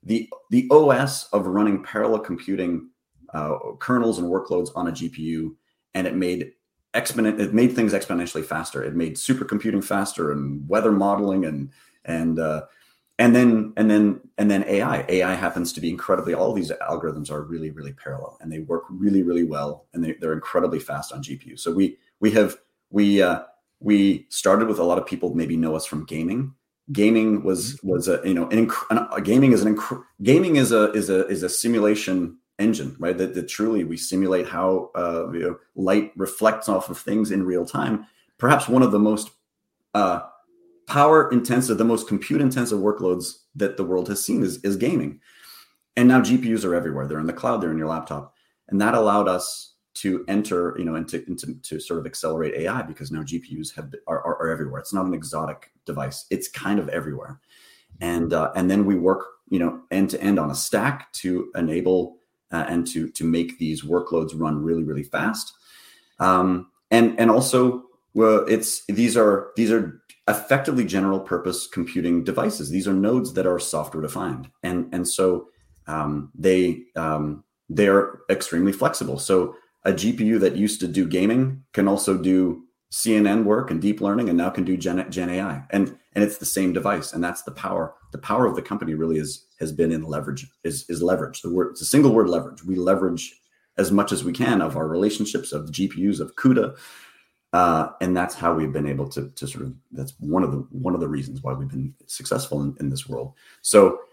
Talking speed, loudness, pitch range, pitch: 200 wpm, -22 LUFS, 85-105 Hz, 95 Hz